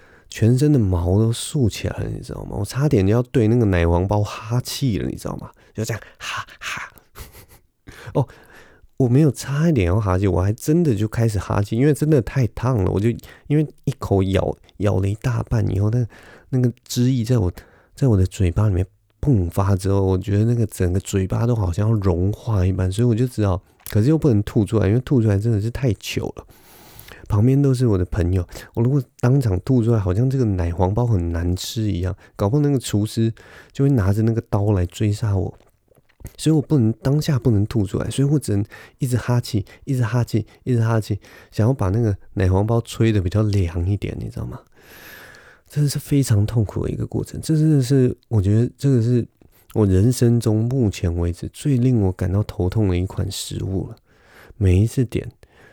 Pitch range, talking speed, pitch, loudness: 100-125 Hz, 295 characters per minute, 110 Hz, -20 LUFS